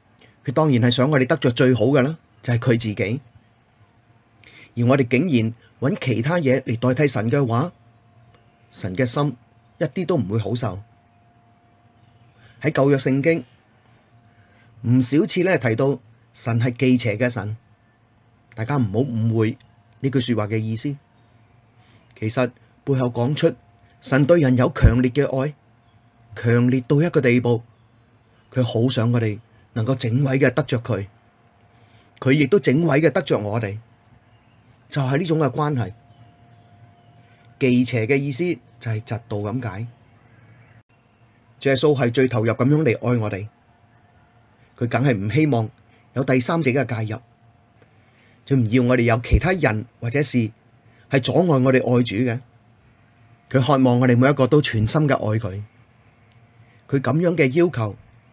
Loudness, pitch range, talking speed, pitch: -20 LUFS, 115-130 Hz, 210 characters per minute, 120 Hz